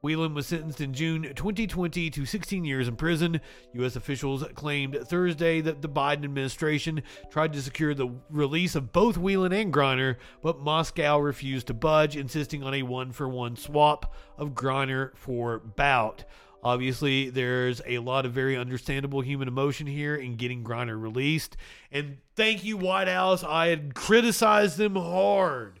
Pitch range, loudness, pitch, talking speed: 130-165 Hz, -27 LUFS, 145 Hz, 160 wpm